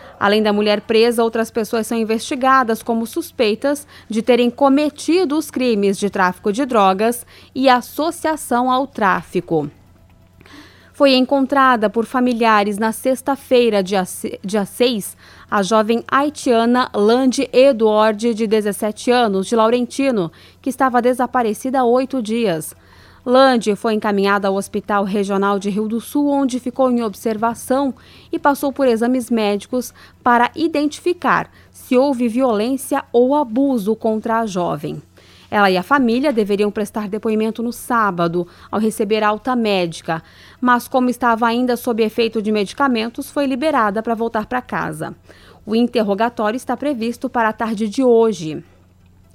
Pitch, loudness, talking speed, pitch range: 230 Hz, -17 LUFS, 135 wpm, 210-255 Hz